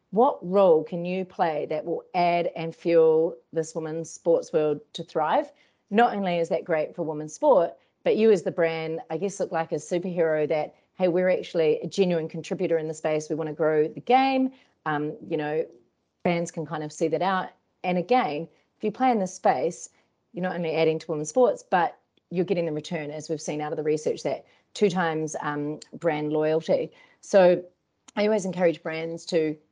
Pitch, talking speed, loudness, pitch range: 165 Hz, 200 wpm, -25 LUFS, 155-185 Hz